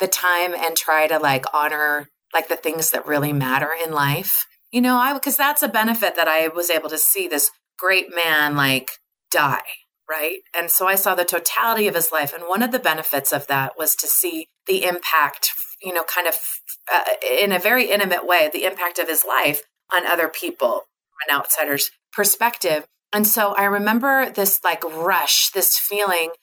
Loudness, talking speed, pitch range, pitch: -19 LUFS, 195 wpm, 155-200 Hz, 170 Hz